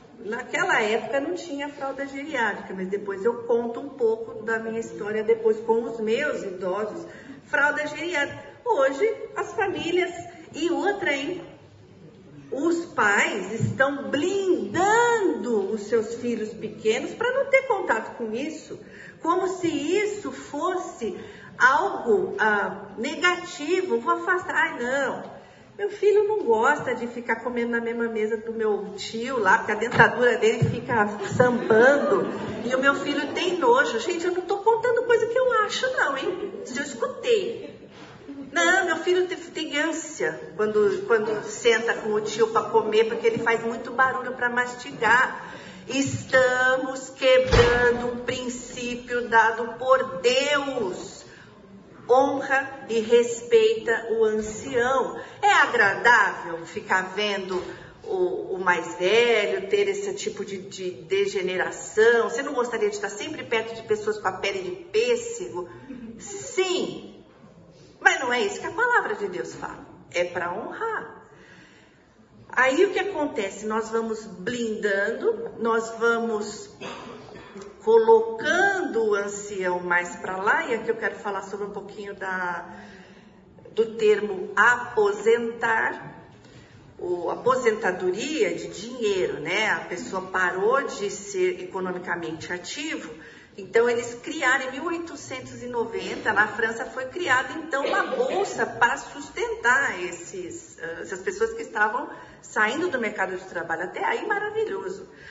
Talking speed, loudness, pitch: 135 wpm, -24 LUFS, 260 Hz